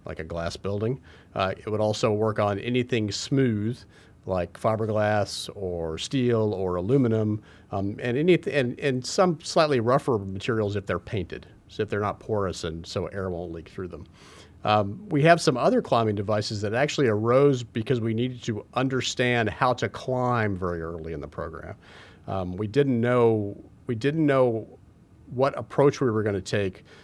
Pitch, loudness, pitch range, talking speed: 110 Hz, -25 LUFS, 100-125 Hz, 175 wpm